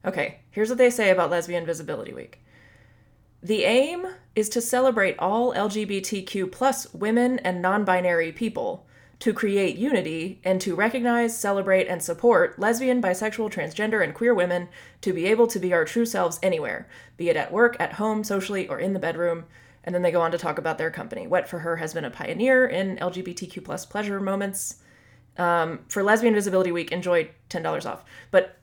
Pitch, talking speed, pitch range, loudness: 190 Hz, 185 wpm, 170-220 Hz, -24 LUFS